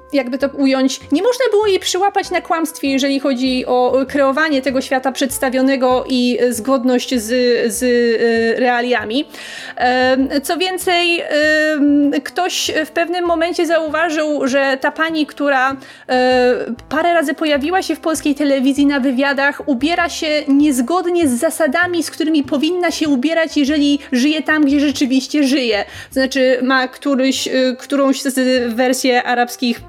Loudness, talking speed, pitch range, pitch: -15 LUFS, 130 wpm, 260-315 Hz, 280 Hz